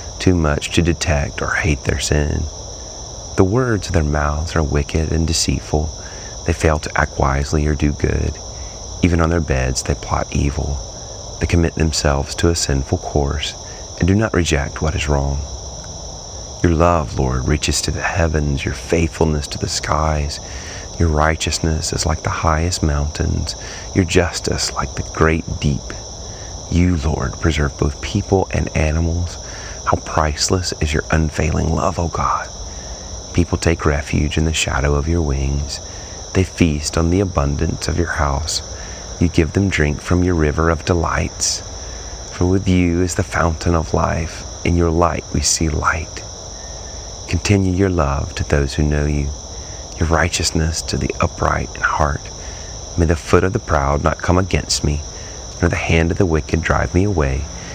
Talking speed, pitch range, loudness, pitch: 165 wpm, 75-90 Hz, -18 LUFS, 85 Hz